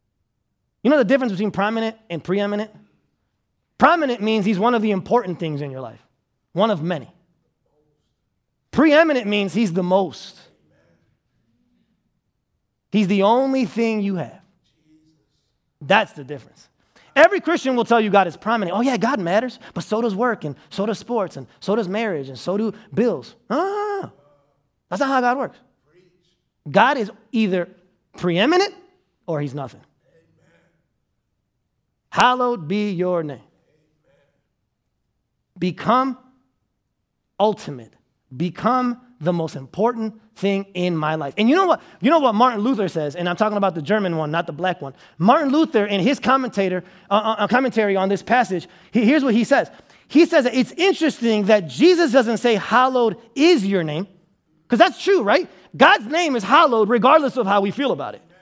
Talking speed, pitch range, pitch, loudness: 160 wpm, 175-250 Hz, 210 Hz, -19 LUFS